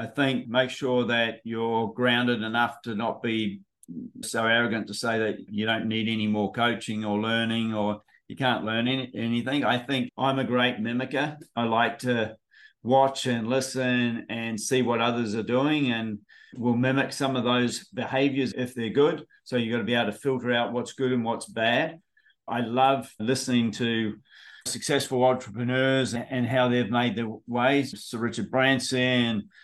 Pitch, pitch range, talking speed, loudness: 120 Hz, 115-130 Hz, 175 wpm, -26 LUFS